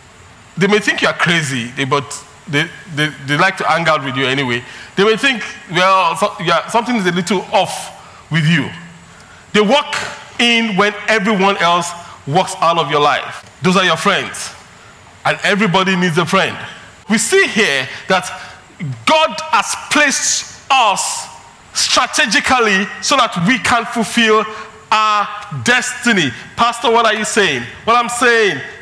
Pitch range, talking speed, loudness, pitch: 165-225 Hz, 155 wpm, -14 LUFS, 200 Hz